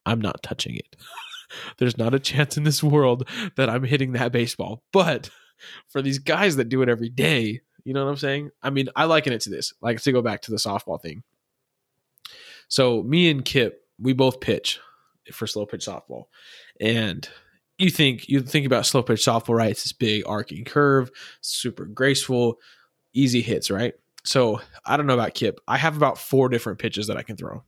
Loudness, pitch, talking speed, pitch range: -23 LUFS, 130 Hz, 200 wpm, 115-140 Hz